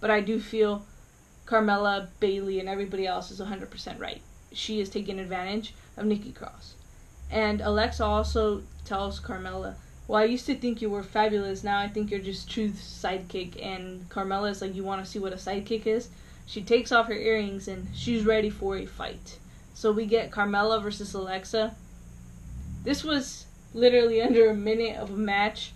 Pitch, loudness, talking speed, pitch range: 210 Hz, -28 LUFS, 180 wpm, 195-220 Hz